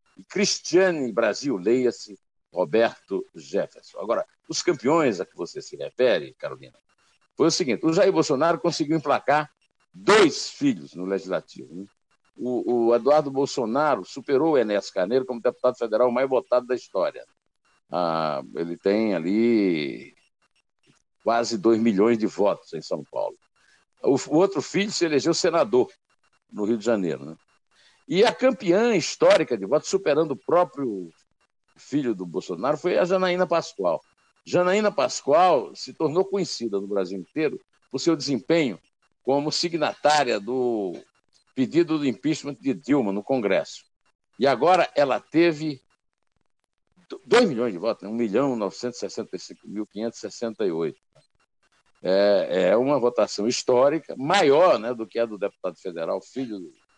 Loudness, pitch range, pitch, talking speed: -23 LUFS, 115-175 Hz, 135 Hz, 135 wpm